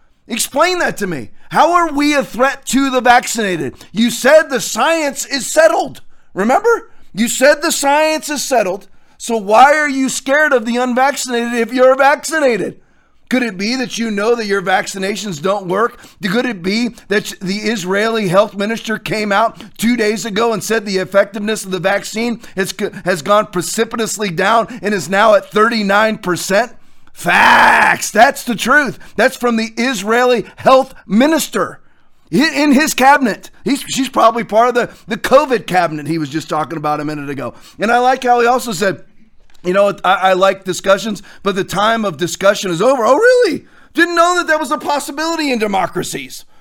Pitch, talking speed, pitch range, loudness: 230 Hz, 180 wpm, 200-270 Hz, -14 LUFS